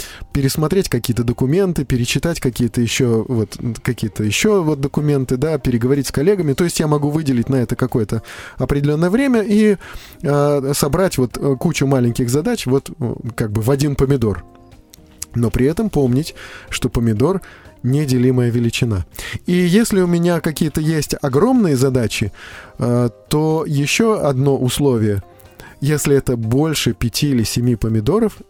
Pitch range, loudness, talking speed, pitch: 120-155 Hz, -17 LUFS, 140 wpm, 135 Hz